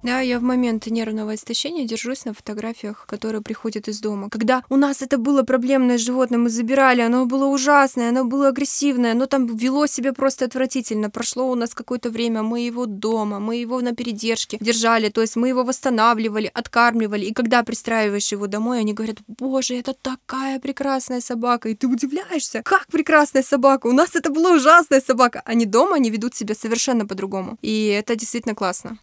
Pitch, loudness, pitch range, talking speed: 245 Hz, -20 LUFS, 225-265 Hz, 180 wpm